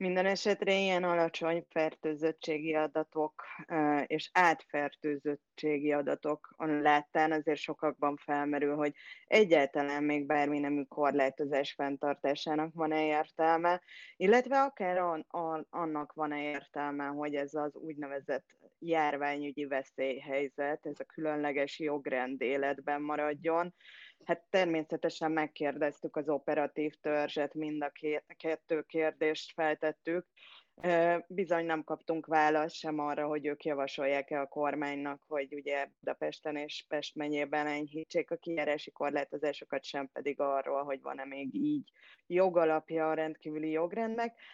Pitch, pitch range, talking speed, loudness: 150 Hz, 145-160 Hz, 115 wpm, -33 LUFS